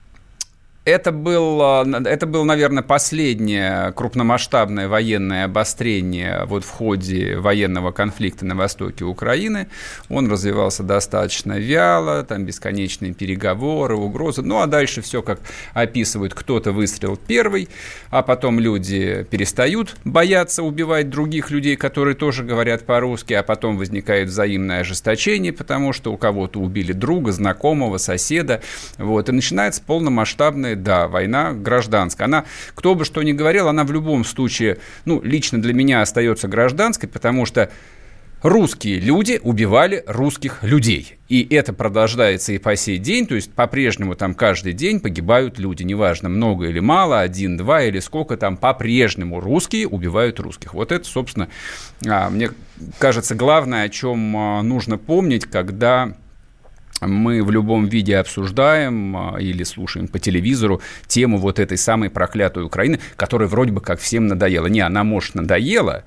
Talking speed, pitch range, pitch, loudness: 140 wpm, 100-130 Hz, 110 Hz, -18 LUFS